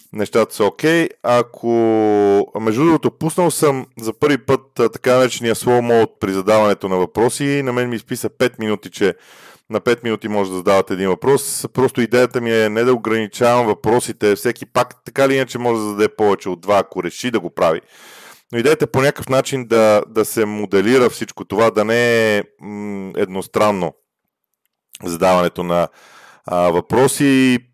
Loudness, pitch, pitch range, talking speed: -17 LUFS, 115 Hz, 105-130 Hz, 175 wpm